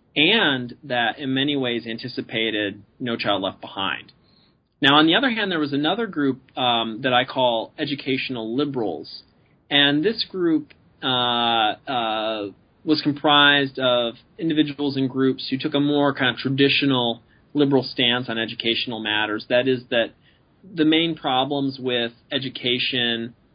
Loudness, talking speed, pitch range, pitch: -21 LUFS, 145 wpm, 120-145 Hz, 130 Hz